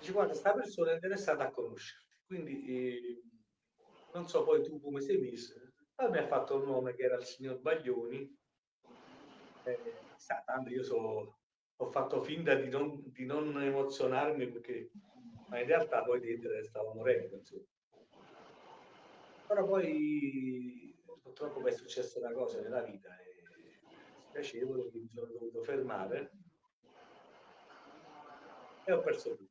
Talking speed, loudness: 145 wpm, -37 LUFS